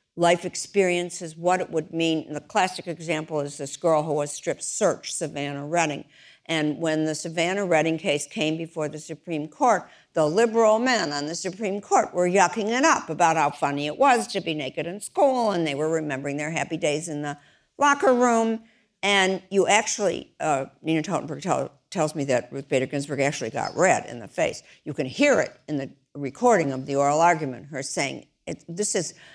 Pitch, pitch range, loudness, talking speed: 160 Hz, 150-190 Hz, -24 LUFS, 200 wpm